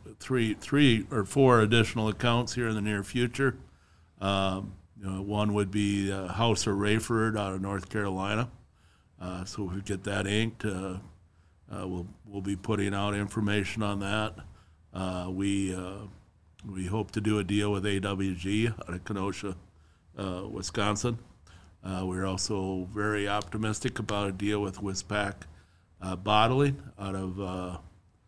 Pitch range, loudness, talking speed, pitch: 95-105 Hz, -30 LUFS, 155 wpm, 100 Hz